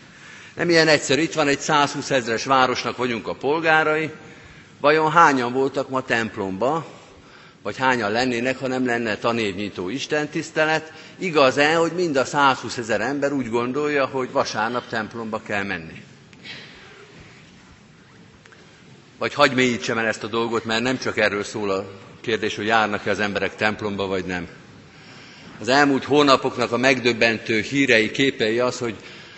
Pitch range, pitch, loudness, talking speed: 115-140 Hz, 125 Hz, -21 LUFS, 140 wpm